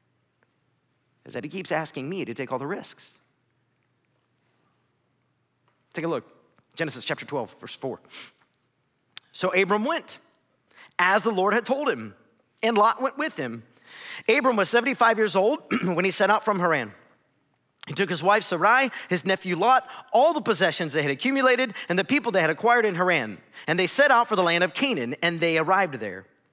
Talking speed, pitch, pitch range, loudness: 180 wpm, 195 Hz, 175-240 Hz, -23 LUFS